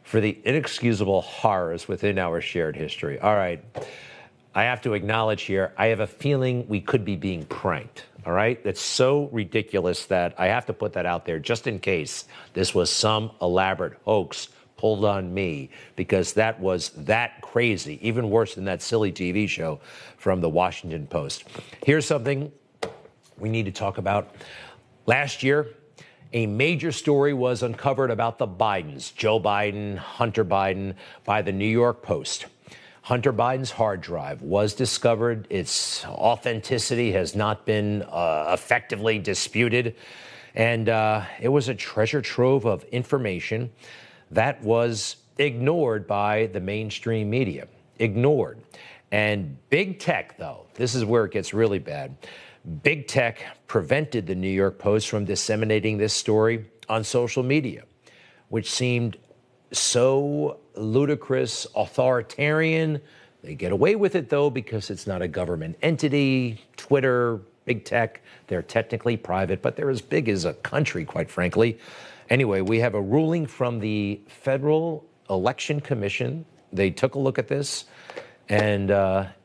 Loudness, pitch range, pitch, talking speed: -24 LUFS, 100-130 Hz, 115 Hz, 150 wpm